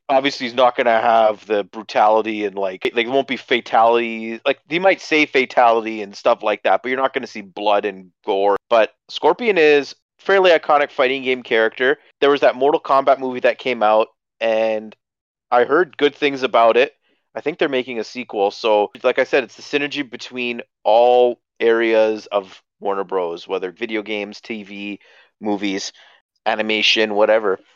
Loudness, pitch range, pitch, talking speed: -18 LUFS, 105-130 Hz, 115 Hz, 180 wpm